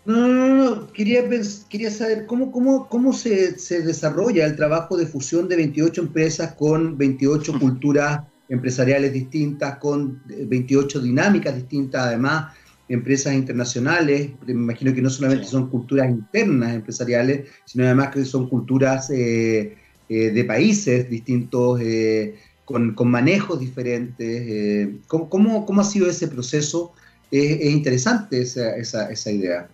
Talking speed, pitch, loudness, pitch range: 140 wpm, 140 Hz, -20 LUFS, 125-165 Hz